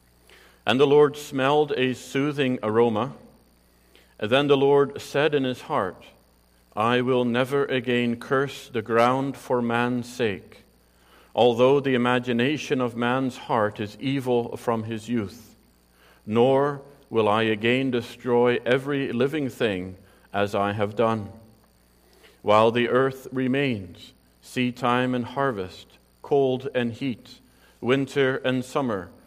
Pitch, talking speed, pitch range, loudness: 120 Hz, 125 wpm, 110-135 Hz, -24 LUFS